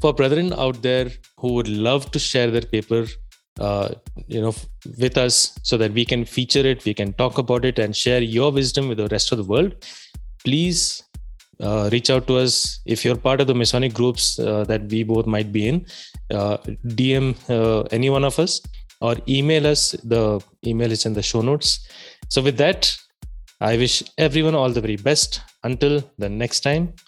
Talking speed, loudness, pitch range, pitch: 195 wpm, -20 LUFS, 110-135 Hz, 125 Hz